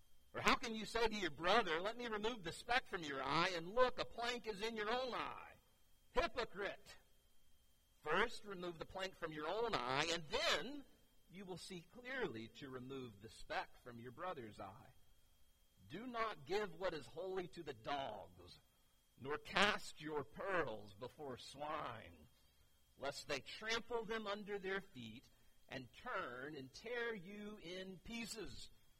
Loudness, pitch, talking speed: -44 LUFS, 180 Hz, 160 wpm